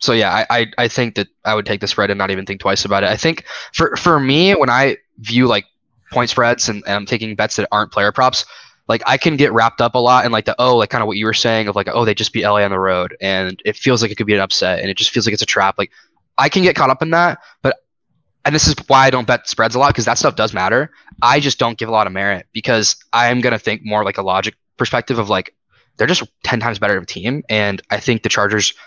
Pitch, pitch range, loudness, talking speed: 110 Hz, 100-125 Hz, -15 LUFS, 295 wpm